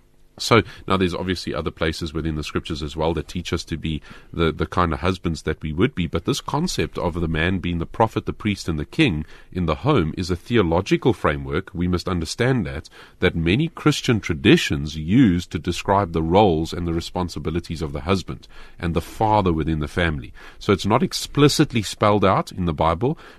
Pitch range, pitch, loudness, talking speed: 80-100 Hz, 90 Hz, -22 LUFS, 205 wpm